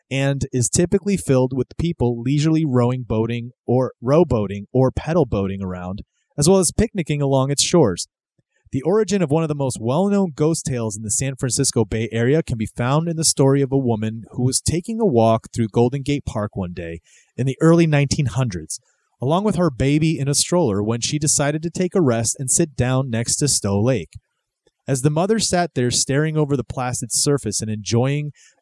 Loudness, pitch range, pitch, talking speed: -19 LUFS, 120-155 Hz, 135 Hz, 200 wpm